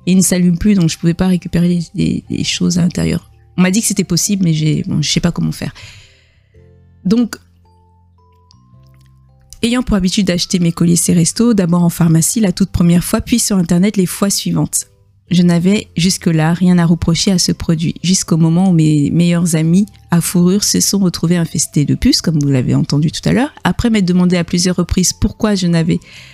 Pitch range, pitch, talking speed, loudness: 150-185 Hz, 175 Hz, 205 wpm, -13 LUFS